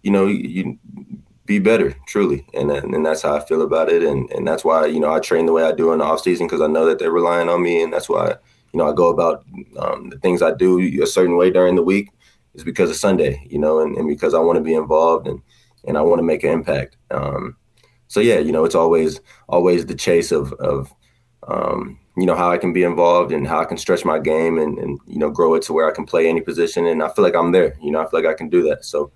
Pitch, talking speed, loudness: 90 Hz, 280 wpm, -18 LUFS